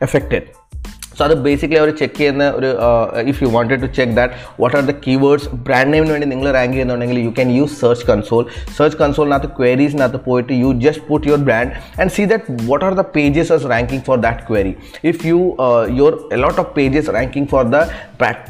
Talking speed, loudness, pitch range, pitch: 195 wpm, -15 LUFS, 125-150 Hz, 135 Hz